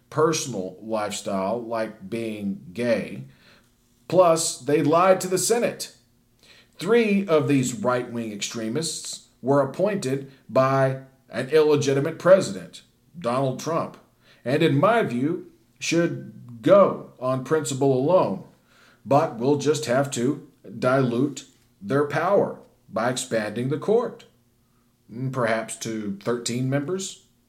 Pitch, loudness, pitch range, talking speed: 130 Hz, -23 LUFS, 115-155 Hz, 110 wpm